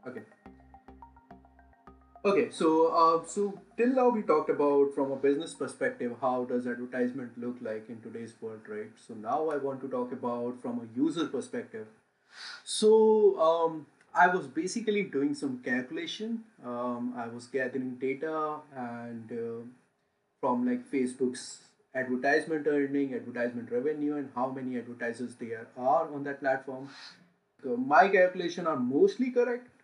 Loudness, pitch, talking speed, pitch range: -30 LUFS, 140 Hz, 145 wpm, 125-200 Hz